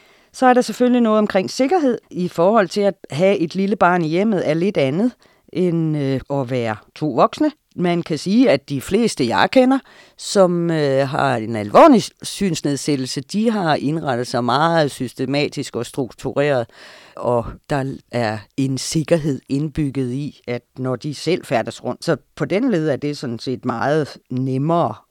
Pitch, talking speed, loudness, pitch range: 150 Hz, 170 wpm, -19 LUFS, 130-190 Hz